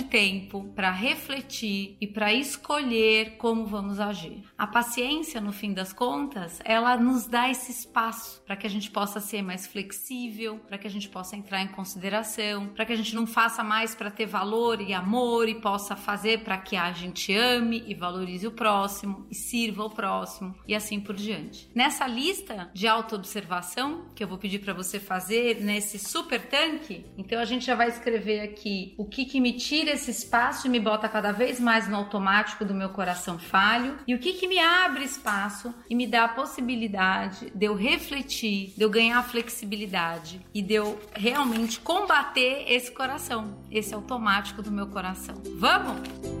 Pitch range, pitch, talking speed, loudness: 200-240 Hz, 220 Hz, 180 wpm, -27 LUFS